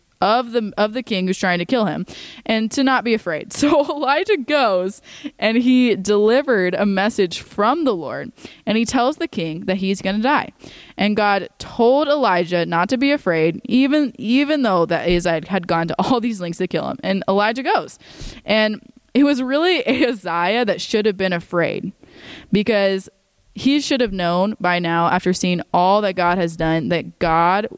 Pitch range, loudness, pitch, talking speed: 180-255 Hz, -18 LUFS, 210 Hz, 190 wpm